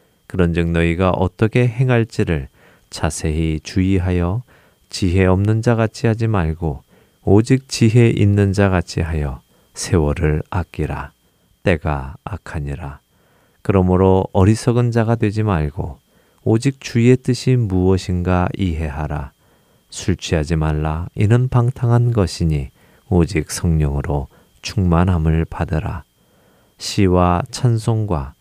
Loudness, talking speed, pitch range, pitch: -18 LUFS, 245 characters per minute, 80-110 Hz, 90 Hz